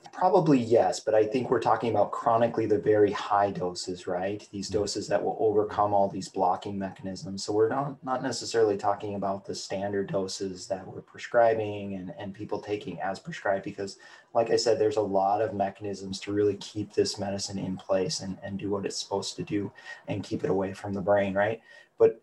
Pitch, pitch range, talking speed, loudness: 100 Hz, 95-110 Hz, 205 wpm, -28 LUFS